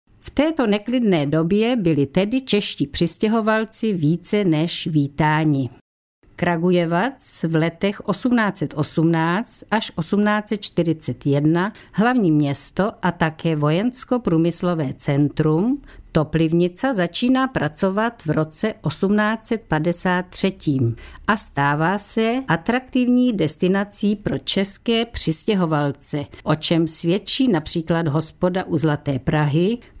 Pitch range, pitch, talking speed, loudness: 155-215 Hz, 175 Hz, 90 wpm, -19 LUFS